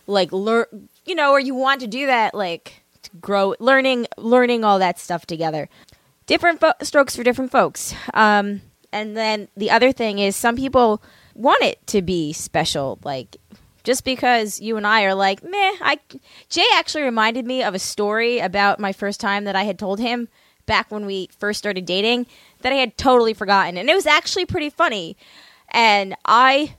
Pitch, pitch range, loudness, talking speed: 220 Hz, 200-255 Hz, -19 LUFS, 190 wpm